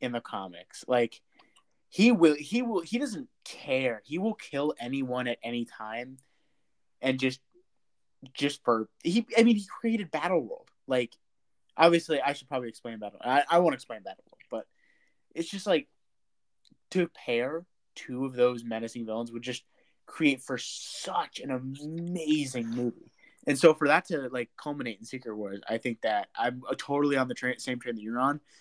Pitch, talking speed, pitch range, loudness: 130 Hz, 175 wpm, 120-165 Hz, -29 LUFS